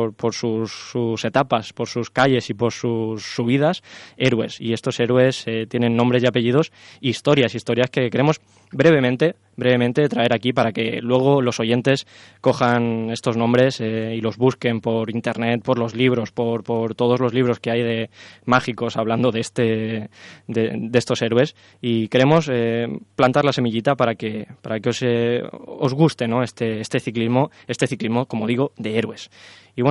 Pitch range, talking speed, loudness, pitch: 115-125 Hz, 175 wpm, -20 LUFS, 120 Hz